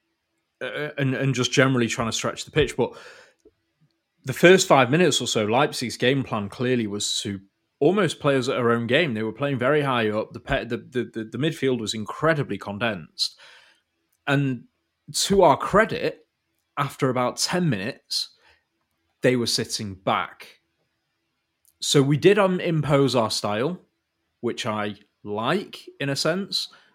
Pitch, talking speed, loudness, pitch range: 130 Hz, 155 wpm, -23 LUFS, 110-150 Hz